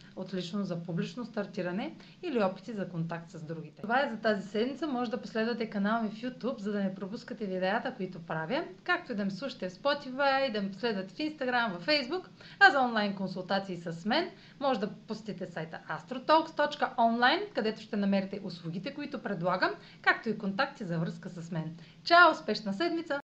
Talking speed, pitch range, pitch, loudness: 180 wpm, 185-255 Hz, 215 Hz, -31 LUFS